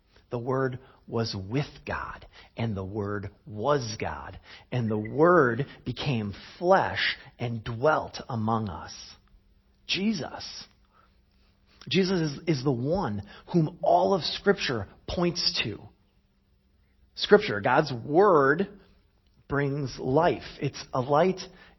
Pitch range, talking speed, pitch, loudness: 110-170 Hz, 105 wpm, 130 Hz, -27 LUFS